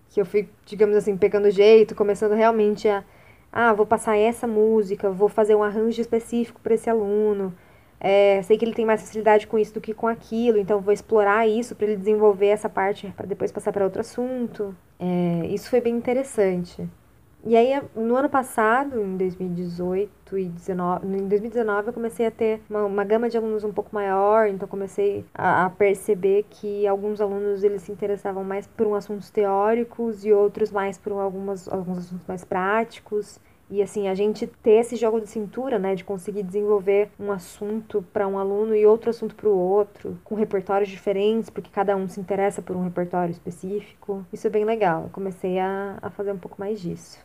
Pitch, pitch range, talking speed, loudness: 205 Hz, 195-220 Hz, 195 wpm, -23 LUFS